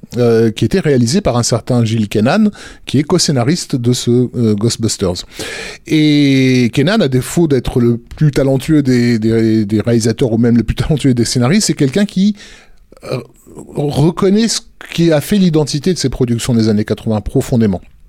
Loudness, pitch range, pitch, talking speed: -13 LUFS, 115-155 Hz, 125 Hz, 175 wpm